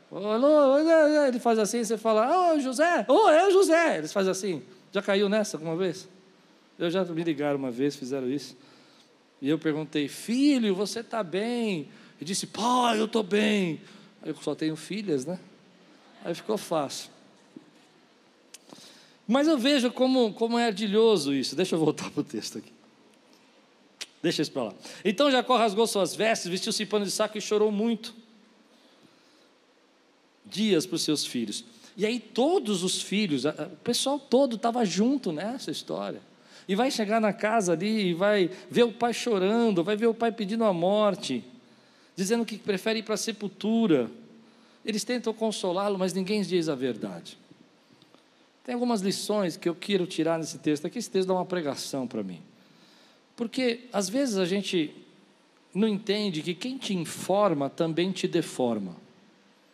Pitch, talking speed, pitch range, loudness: 210 Hz, 165 wpm, 180-240 Hz, -27 LUFS